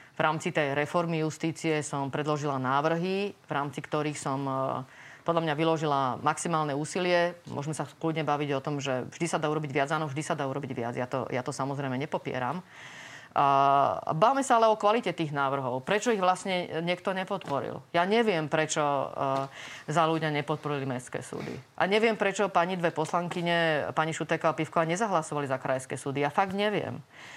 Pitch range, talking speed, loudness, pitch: 140-175 Hz, 170 wpm, -29 LUFS, 155 Hz